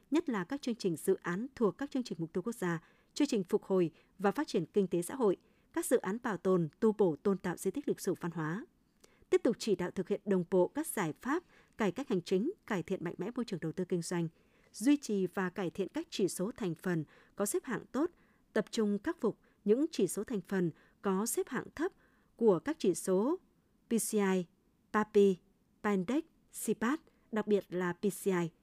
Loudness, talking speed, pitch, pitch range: -34 LUFS, 220 wpm, 200 Hz, 185-235 Hz